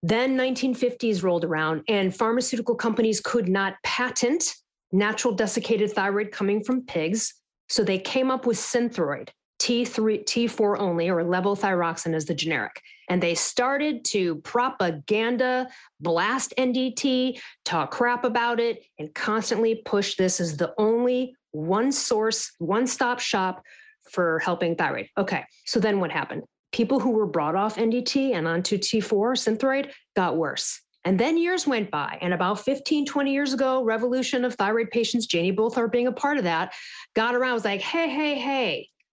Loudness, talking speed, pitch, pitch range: -25 LUFS, 160 wpm, 230 Hz, 195-255 Hz